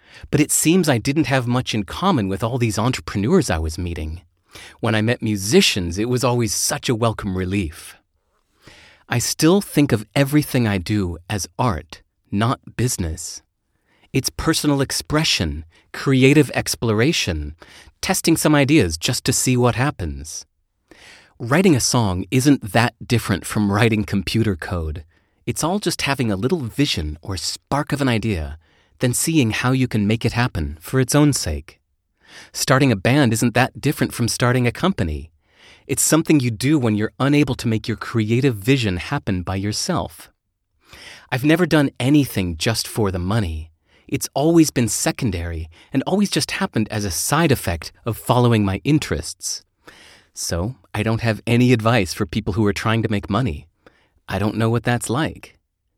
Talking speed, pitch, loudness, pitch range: 165 wpm, 115 Hz, -19 LUFS, 95-135 Hz